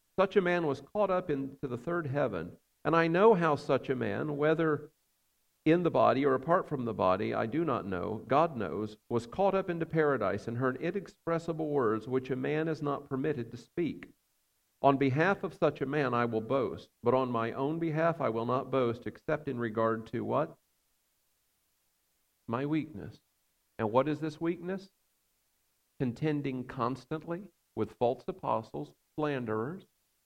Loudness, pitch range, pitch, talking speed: -31 LUFS, 120-165 Hz, 140 Hz, 170 wpm